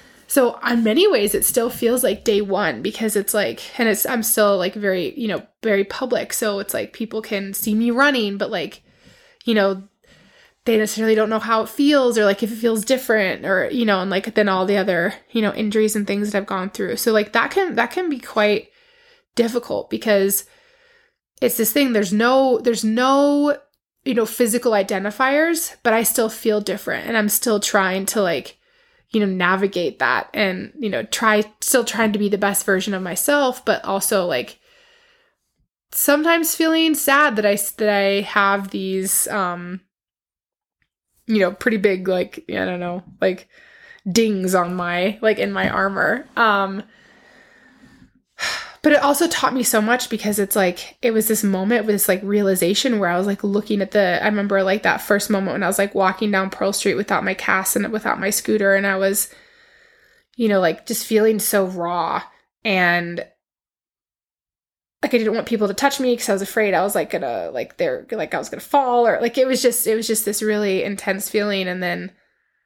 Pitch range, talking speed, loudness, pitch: 200-255 Hz, 195 wpm, -19 LUFS, 215 Hz